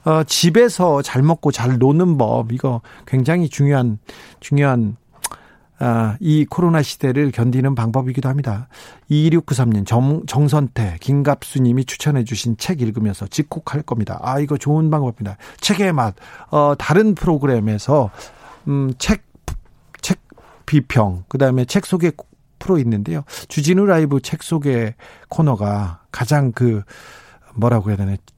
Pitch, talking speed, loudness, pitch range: 135 Hz, 270 characters per minute, -18 LUFS, 115-155 Hz